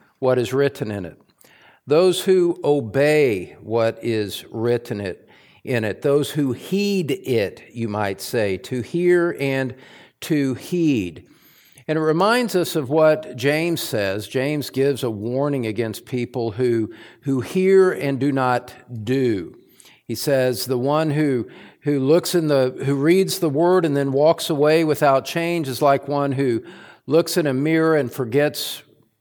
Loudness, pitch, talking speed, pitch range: -20 LUFS, 140 Hz, 155 wpm, 125-160 Hz